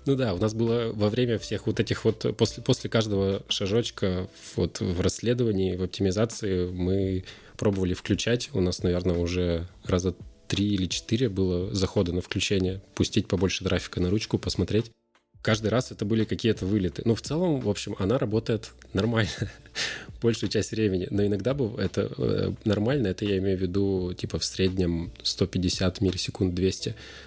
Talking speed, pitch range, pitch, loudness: 165 wpm, 95-110 Hz, 100 Hz, -27 LUFS